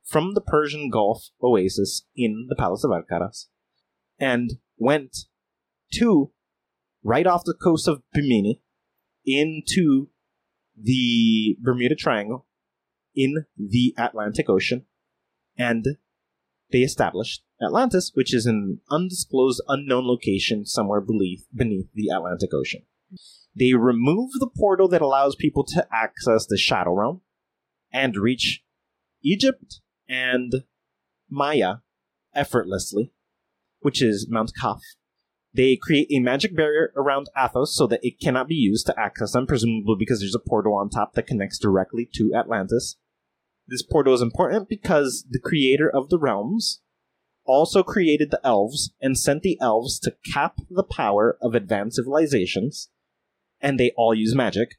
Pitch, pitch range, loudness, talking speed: 130 Hz, 110-150 Hz, -22 LUFS, 135 wpm